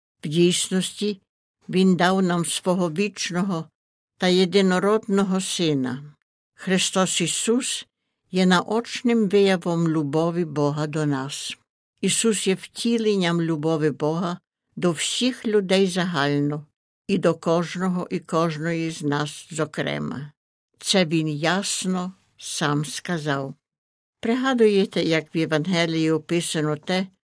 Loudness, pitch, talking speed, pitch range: -23 LUFS, 175 Hz, 105 wpm, 160-190 Hz